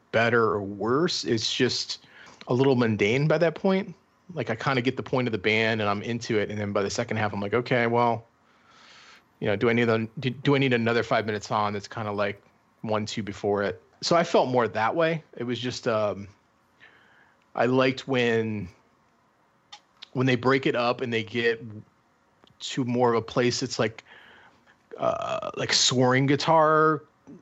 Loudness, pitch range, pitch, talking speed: -25 LUFS, 110-130 Hz, 120 Hz, 195 wpm